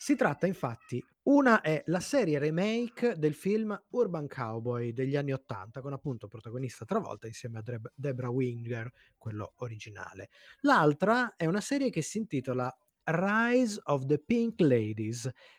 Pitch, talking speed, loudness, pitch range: 145 Hz, 140 wpm, -31 LUFS, 120-205 Hz